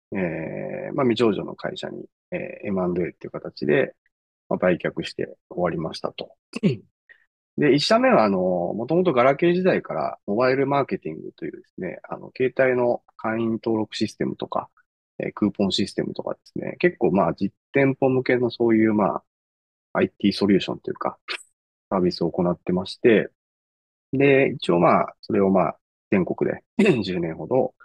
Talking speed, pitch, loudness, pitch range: 325 characters per minute, 120 Hz, -23 LUFS, 100-140 Hz